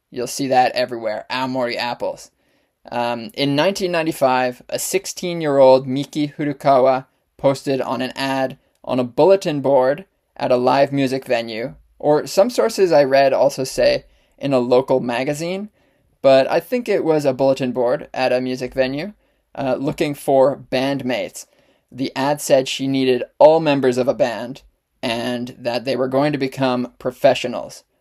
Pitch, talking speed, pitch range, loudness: 135 Hz, 155 wpm, 130-150 Hz, -18 LUFS